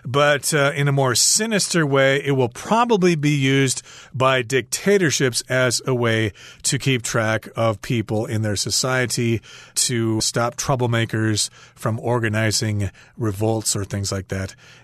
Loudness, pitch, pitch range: -20 LUFS, 125 Hz, 110-140 Hz